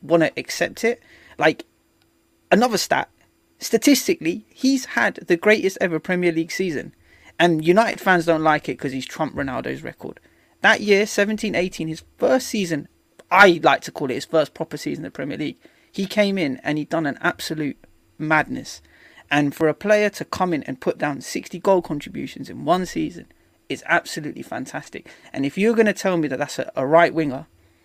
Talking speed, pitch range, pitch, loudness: 185 wpm, 155-215 Hz, 180 Hz, -21 LUFS